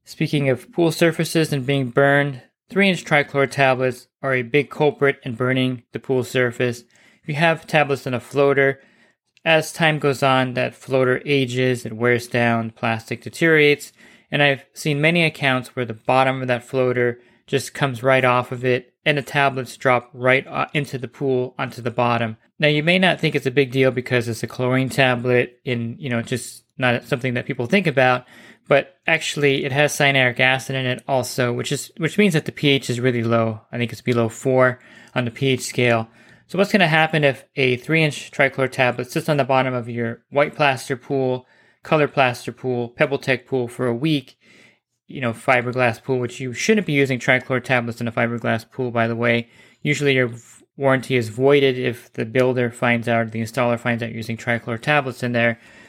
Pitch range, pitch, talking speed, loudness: 120-140 Hz, 130 Hz, 195 wpm, -20 LUFS